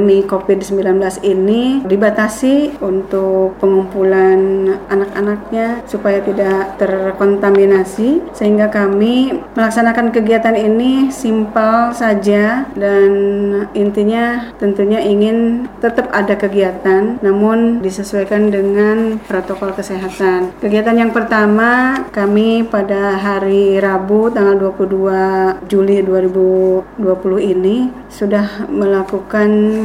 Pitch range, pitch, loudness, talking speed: 195-220 Hz, 200 Hz, -13 LUFS, 85 wpm